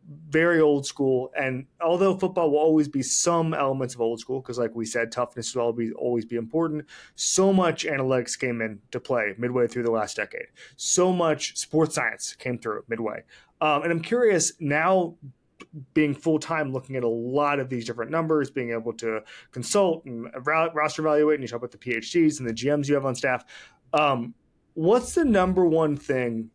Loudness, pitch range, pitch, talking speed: -25 LUFS, 120-160 Hz, 140 Hz, 190 wpm